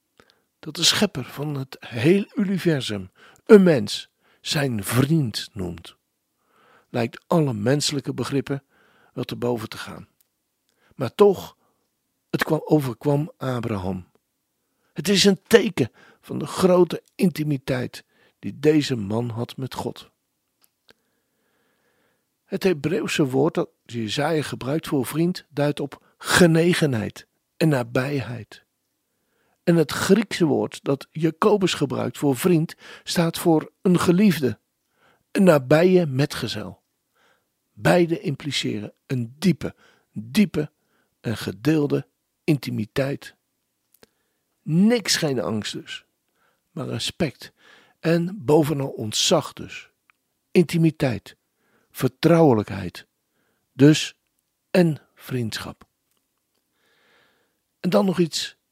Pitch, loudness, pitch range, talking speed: 150 Hz, -22 LUFS, 130-175 Hz, 100 wpm